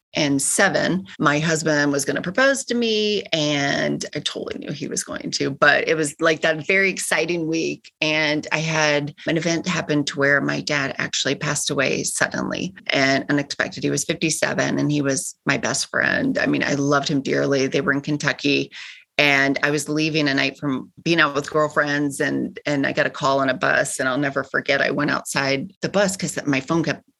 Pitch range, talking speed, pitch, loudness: 140-165 Hz, 205 wpm, 150 Hz, -20 LUFS